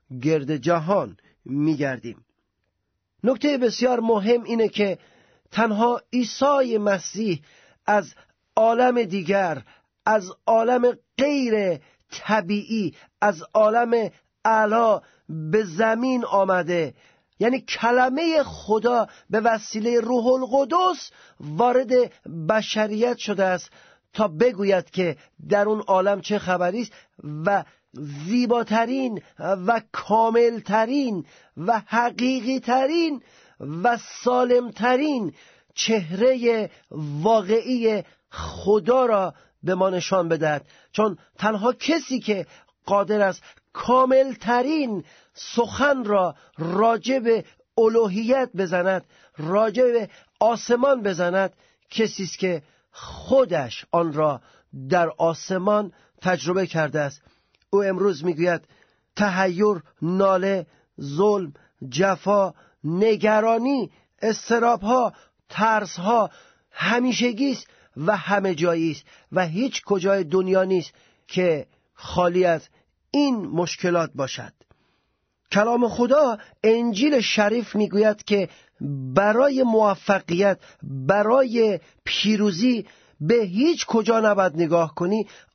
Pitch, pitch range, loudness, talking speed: 210 Hz, 180-235 Hz, -22 LUFS, 95 wpm